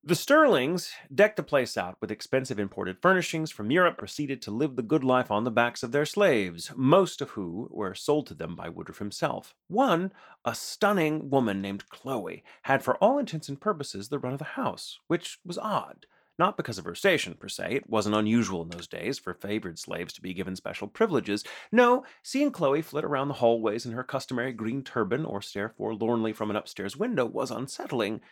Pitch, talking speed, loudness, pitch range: 130 Hz, 205 wpm, -28 LUFS, 110-155 Hz